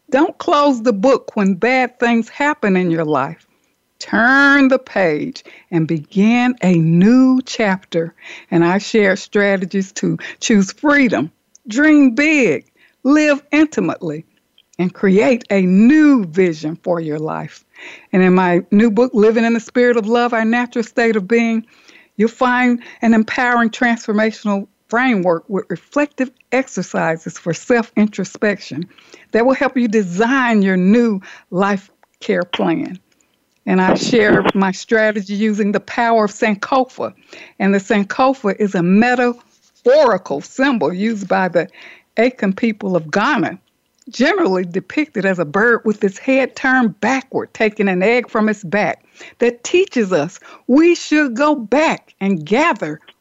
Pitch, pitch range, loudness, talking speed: 225 Hz, 195-255 Hz, -15 LUFS, 140 wpm